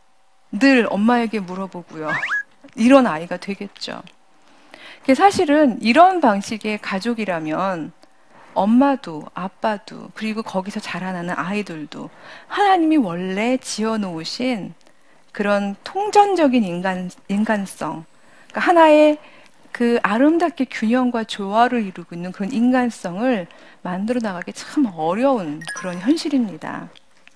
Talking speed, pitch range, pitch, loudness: 260 characters per minute, 190-270 Hz, 225 Hz, -19 LUFS